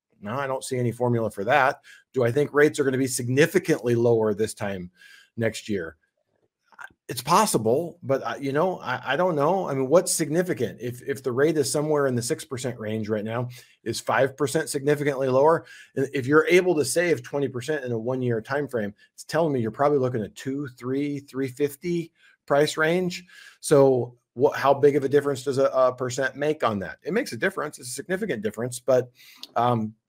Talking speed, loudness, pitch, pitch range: 195 wpm, -24 LUFS, 135 Hz, 120-150 Hz